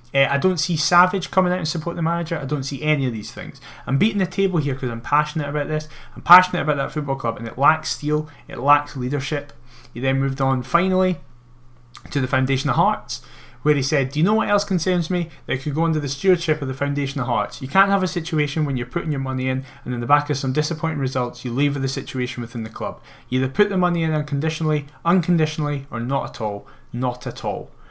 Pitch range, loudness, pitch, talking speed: 130-165 Hz, -21 LUFS, 145 Hz, 245 wpm